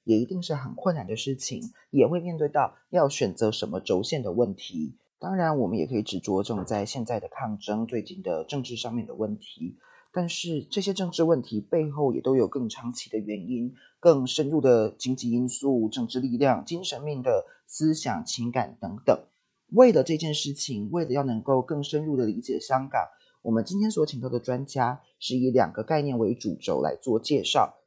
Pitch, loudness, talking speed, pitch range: 130 Hz, -27 LUFS, 290 characters per minute, 120-155 Hz